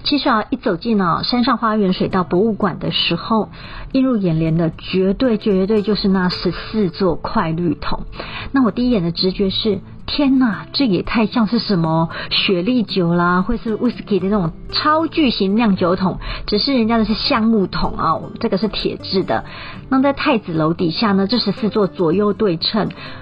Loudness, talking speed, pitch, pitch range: -17 LUFS, 285 characters per minute, 205 Hz, 180-230 Hz